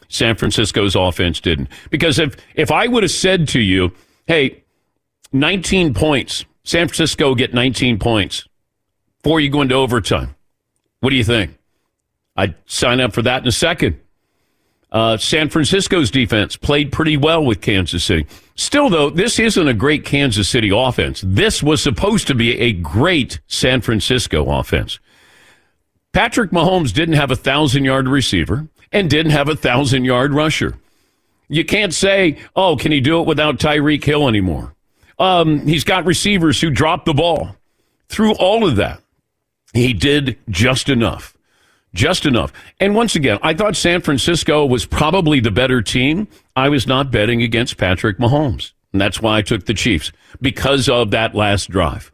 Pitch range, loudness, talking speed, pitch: 110-155 Hz, -15 LUFS, 165 wpm, 135 Hz